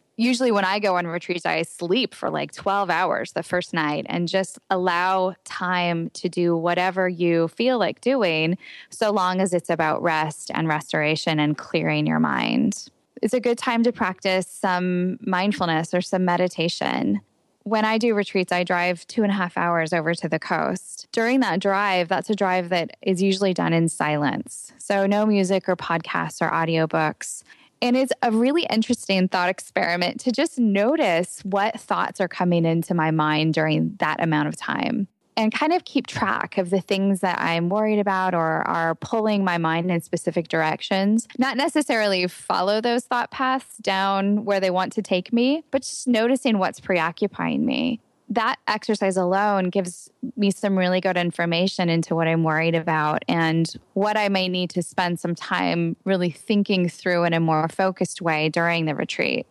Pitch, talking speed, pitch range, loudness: 185 Hz, 180 wpm, 170-210 Hz, -22 LUFS